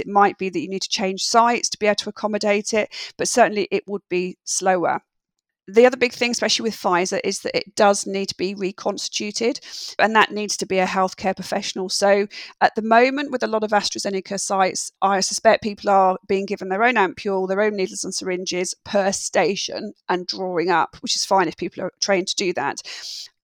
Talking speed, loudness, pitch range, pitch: 215 wpm, -21 LUFS, 190-215 Hz, 200 Hz